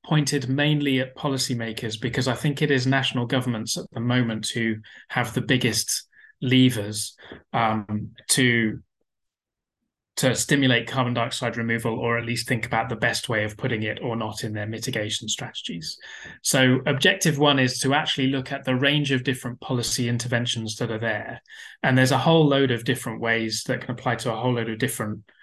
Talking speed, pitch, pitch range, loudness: 180 wpm, 125 Hz, 115-130 Hz, -23 LUFS